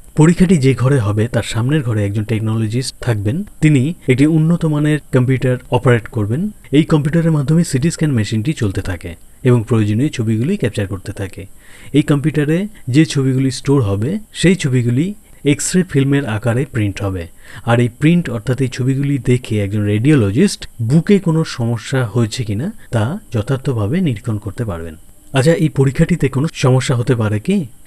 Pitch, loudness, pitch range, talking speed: 130 Hz, -16 LUFS, 110-150 Hz, 155 wpm